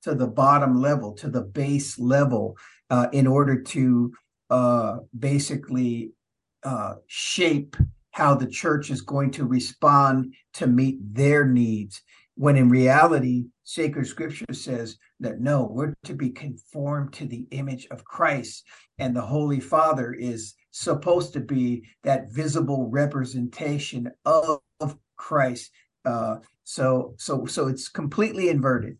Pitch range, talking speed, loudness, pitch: 125-145 Hz, 130 wpm, -24 LUFS, 135 Hz